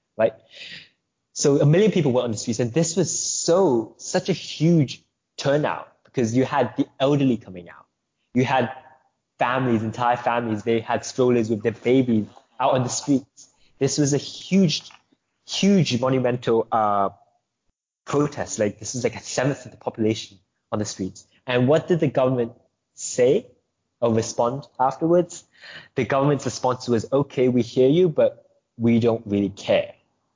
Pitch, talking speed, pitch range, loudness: 125 Hz, 160 wpm, 115-145 Hz, -22 LUFS